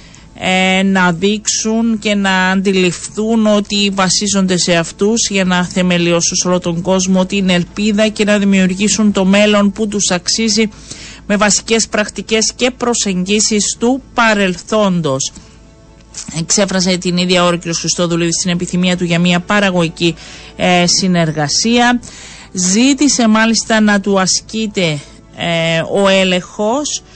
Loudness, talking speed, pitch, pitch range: -13 LUFS, 120 wpm, 190 Hz, 175-215 Hz